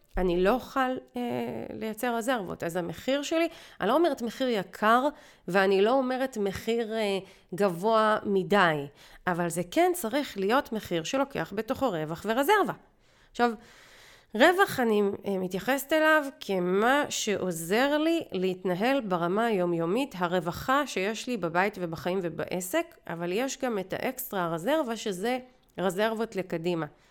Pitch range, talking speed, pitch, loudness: 180-260 Hz, 130 wpm, 215 Hz, -28 LUFS